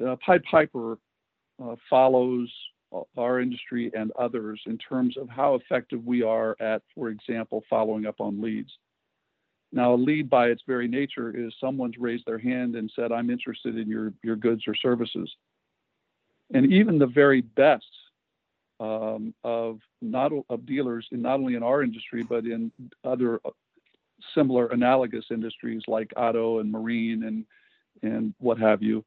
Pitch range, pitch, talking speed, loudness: 110-125 Hz, 115 Hz, 155 wpm, -26 LUFS